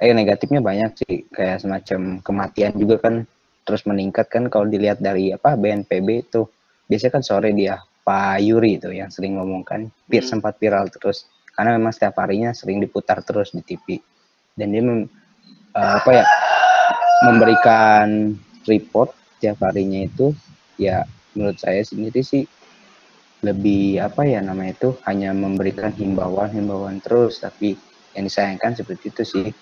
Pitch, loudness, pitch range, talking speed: 105 Hz, -19 LUFS, 95-115 Hz, 145 wpm